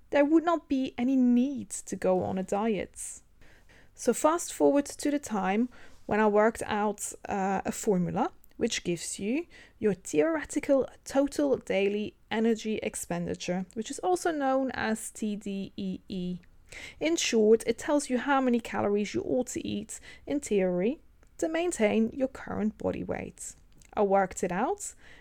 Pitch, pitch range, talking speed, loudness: 225 Hz, 200-275 Hz, 150 wpm, -29 LUFS